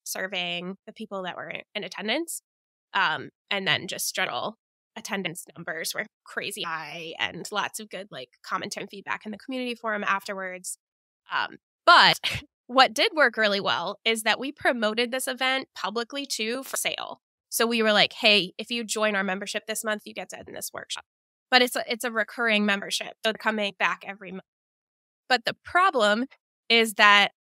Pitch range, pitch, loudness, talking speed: 195-245 Hz, 215 Hz, -25 LUFS, 180 wpm